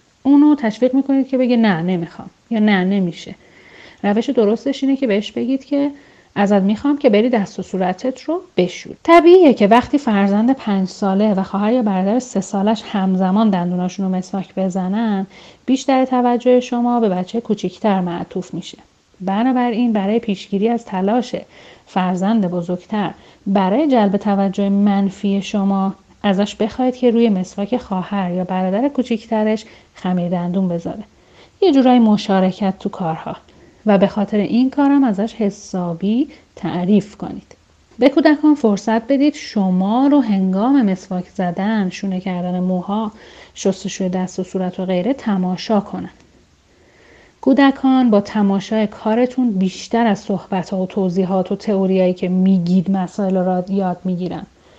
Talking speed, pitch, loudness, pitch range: 140 wpm, 205 Hz, -17 LUFS, 190-240 Hz